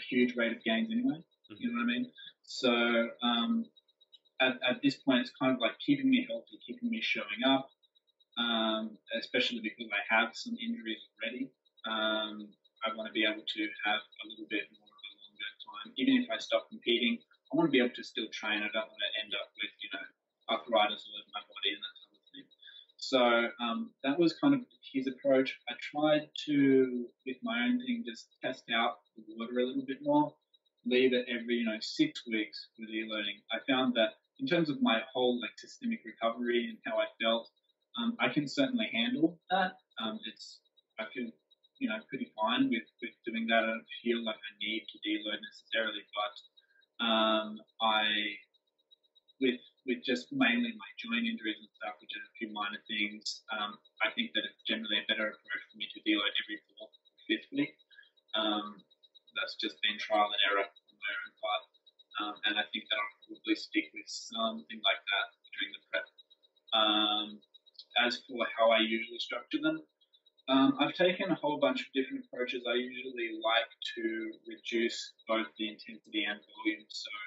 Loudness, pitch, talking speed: -33 LUFS, 125 Hz, 190 wpm